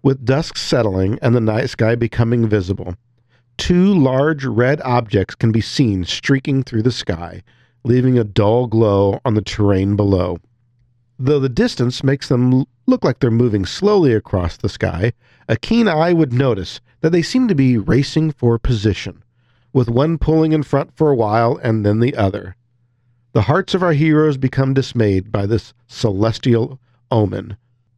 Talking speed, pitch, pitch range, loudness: 165 wpm, 120 Hz, 110-135 Hz, -17 LUFS